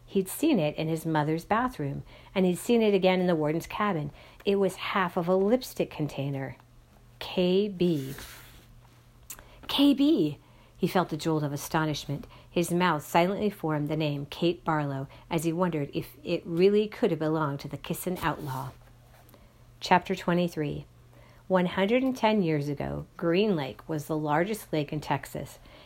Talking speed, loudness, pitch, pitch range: 150 wpm, -28 LUFS, 160 Hz, 140-185 Hz